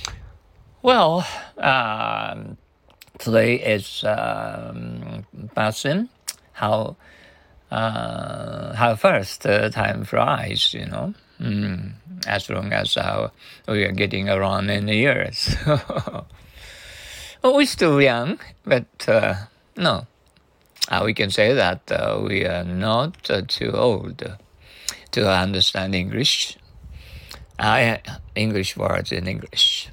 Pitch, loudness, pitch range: 105 Hz, -21 LUFS, 95-140 Hz